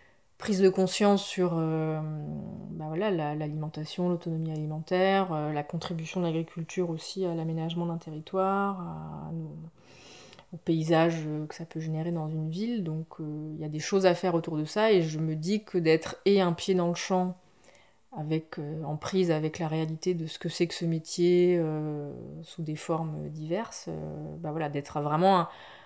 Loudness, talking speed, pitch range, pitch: -29 LUFS, 185 wpm, 155-180 Hz, 165 Hz